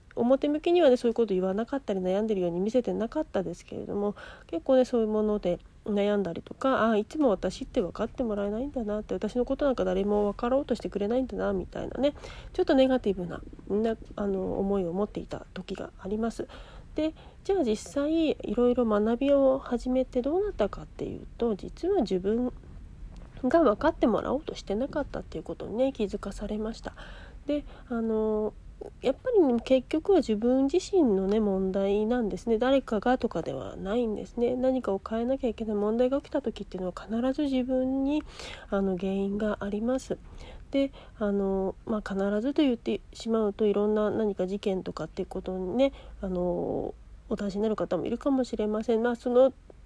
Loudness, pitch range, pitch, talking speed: -28 LUFS, 205-260 Hz, 225 Hz, 390 characters per minute